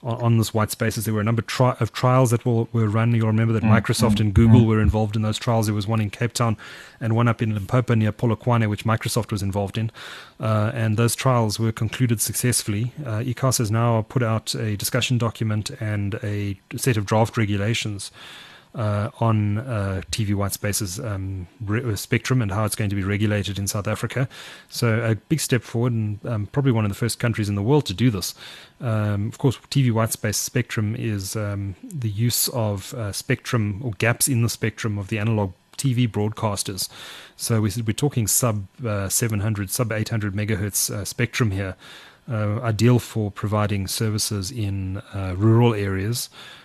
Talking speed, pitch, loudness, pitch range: 190 wpm, 110 Hz, -23 LUFS, 105-120 Hz